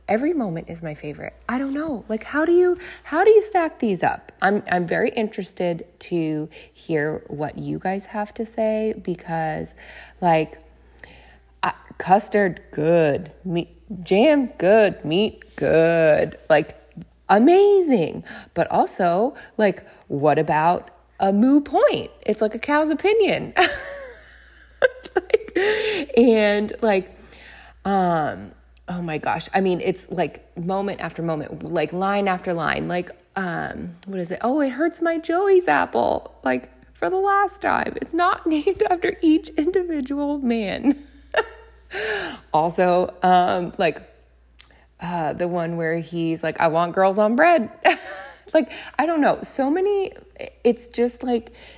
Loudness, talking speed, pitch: -21 LUFS, 135 wpm, 215 Hz